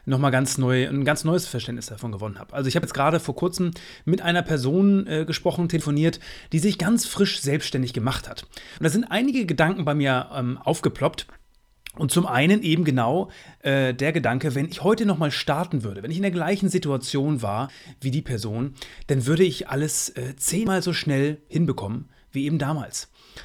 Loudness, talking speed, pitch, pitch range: -24 LUFS, 190 wpm, 150 Hz, 130-175 Hz